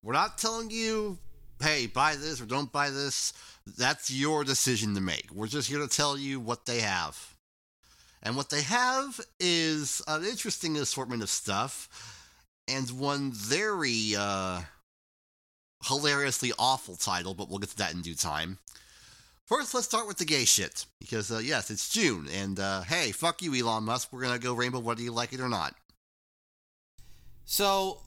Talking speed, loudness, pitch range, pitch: 175 wpm, -29 LUFS, 100-150 Hz, 125 Hz